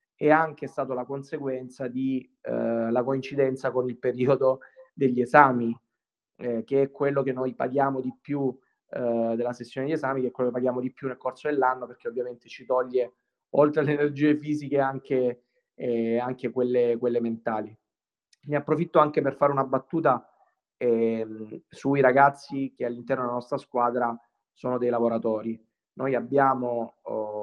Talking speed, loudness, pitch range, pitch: 160 wpm, -26 LUFS, 120-140 Hz, 130 Hz